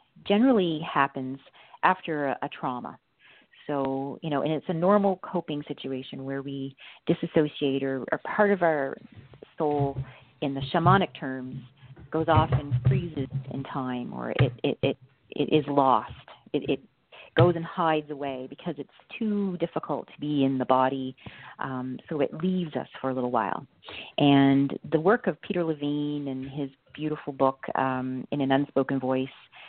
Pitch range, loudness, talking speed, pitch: 130-160 Hz, -27 LUFS, 160 wpm, 140 Hz